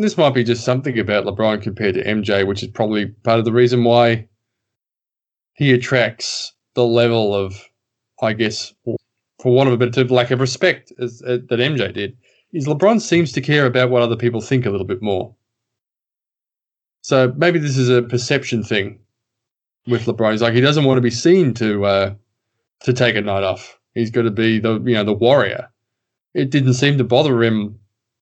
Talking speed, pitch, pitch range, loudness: 200 wpm, 120 Hz, 110-125 Hz, -17 LUFS